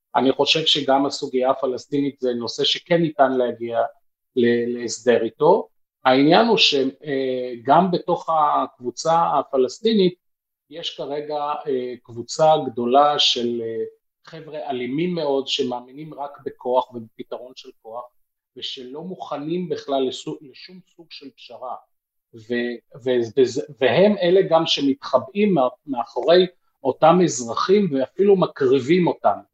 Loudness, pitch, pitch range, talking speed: -20 LUFS, 140 Hz, 125-165 Hz, 100 wpm